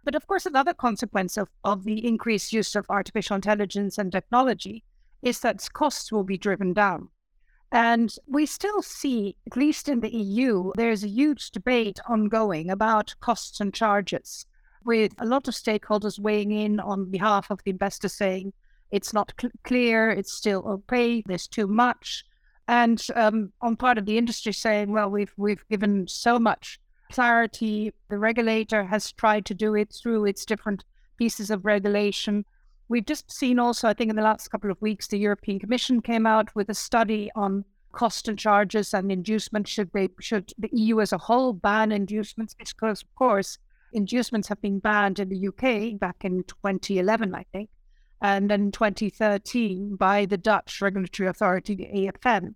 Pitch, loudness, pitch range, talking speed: 215 Hz, -25 LUFS, 200-230 Hz, 180 wpm